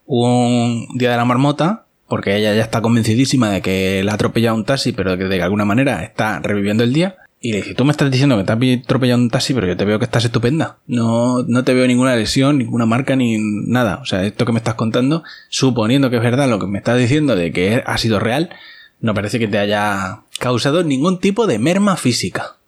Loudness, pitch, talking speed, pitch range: -16 LUFS, 120 Hz, 235 wpm, 110-130 Hz